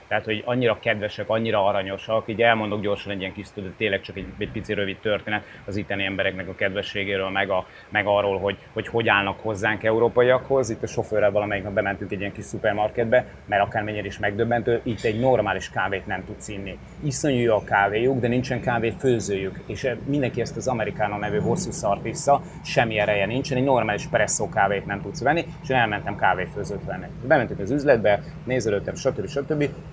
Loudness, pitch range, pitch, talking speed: -24 LUFS, 100-120 Hz, 105 Hz, 190 wpm